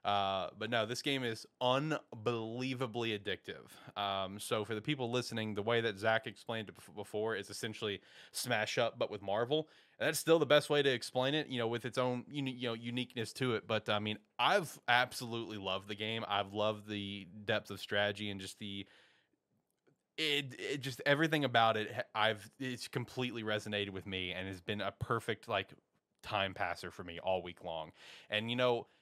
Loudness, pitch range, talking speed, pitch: -36 LUFS, 100-125 Hz, 190 wpm, 115 Hz